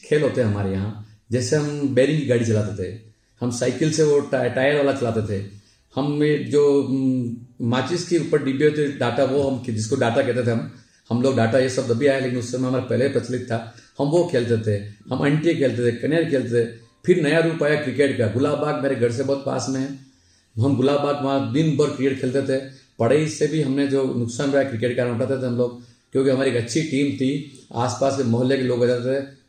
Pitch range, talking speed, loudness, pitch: 120-140 Hz, 235 wpm, -21 LUFS, 130 Hz